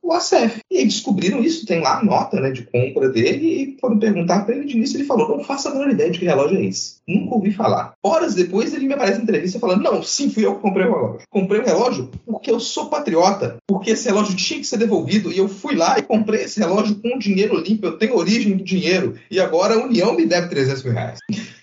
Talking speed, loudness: 255 wpm, -19 LUFS